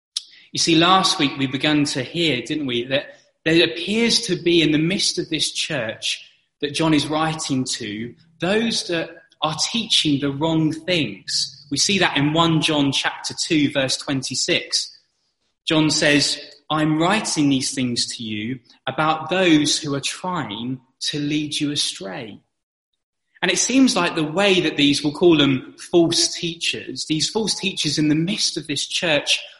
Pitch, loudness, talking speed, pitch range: 155 Hz, -20 LUFS, 165 wpm, 145-170 Hz